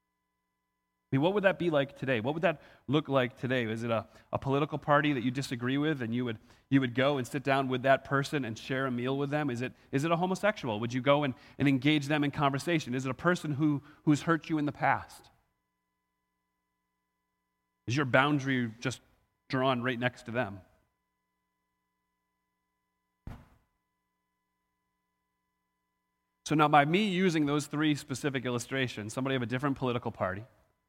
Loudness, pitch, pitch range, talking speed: -30 LUFS, 130 Hz, 100-145 Hz, 180 wpm